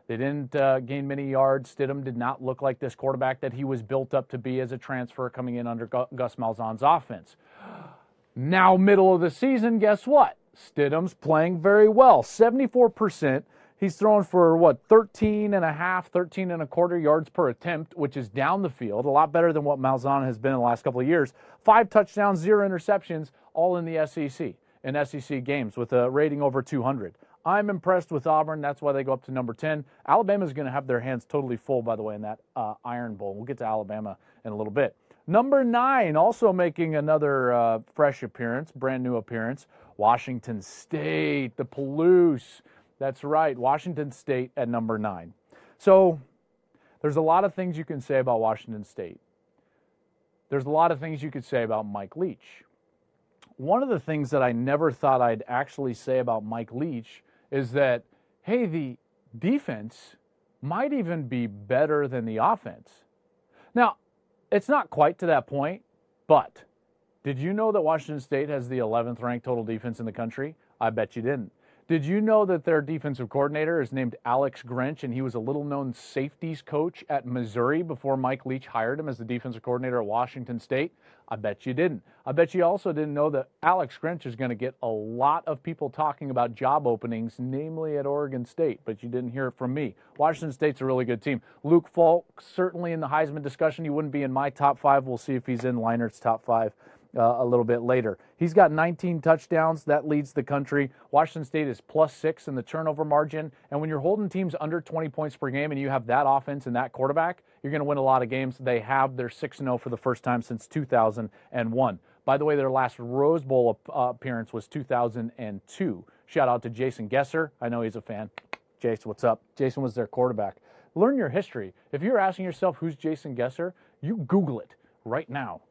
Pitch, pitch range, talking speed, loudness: 140 Hz, 125-160 Hz, 200 wpm, -26 LUFS